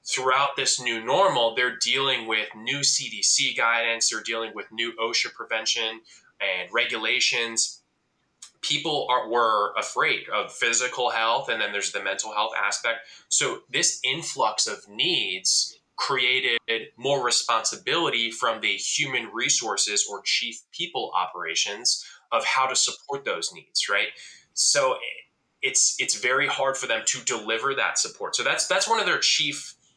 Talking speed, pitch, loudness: 145 wpm, 125 Hz, -23 LUFS